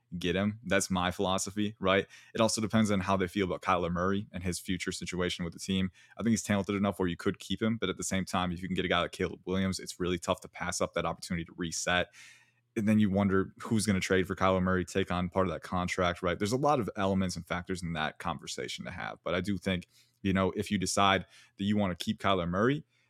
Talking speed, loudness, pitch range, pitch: 270 wpm, -31 LUFS, 90-100 Hz, 95 Hz